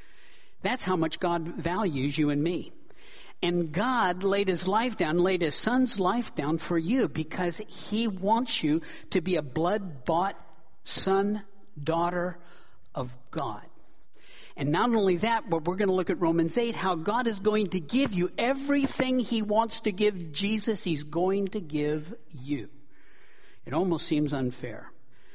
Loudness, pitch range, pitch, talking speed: -28 LUFS, 165-225 Hz, 185 Hz, 160 wpm